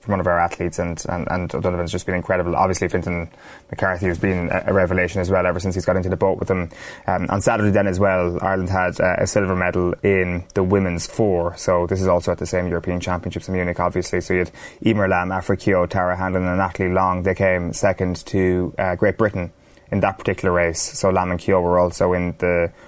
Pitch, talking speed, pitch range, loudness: 90 Hz, 235 wpm, 90-95 Hz, -20 LUFS